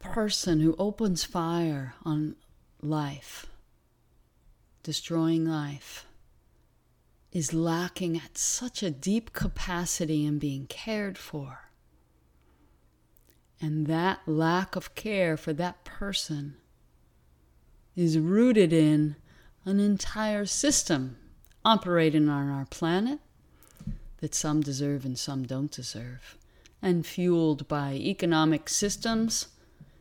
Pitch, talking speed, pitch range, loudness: 160 Hz, 100 wpm, 140-185 Hz, -28 LUFS